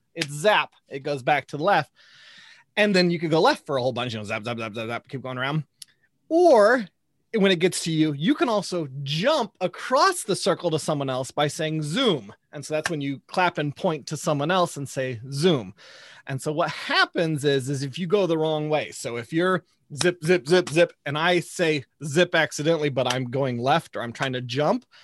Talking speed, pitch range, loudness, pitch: 225 wpm, 140-180 Hz, -24 LUFS, 155 Hz